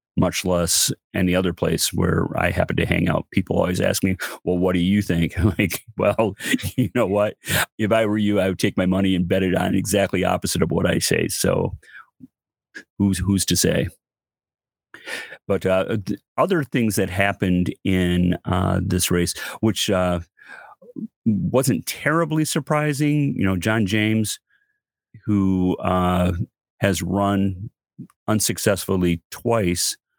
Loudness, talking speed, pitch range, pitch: -21 LUFS, 150 wpm, 90-110 Hz, 95 Hz